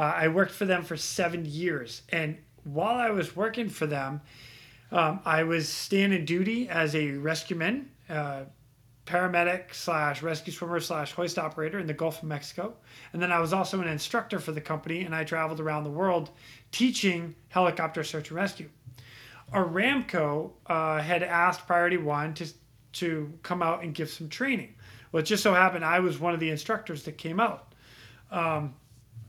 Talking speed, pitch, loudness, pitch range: 180 wpm, 165 Hz, -29 LUFS, 150-180 Hz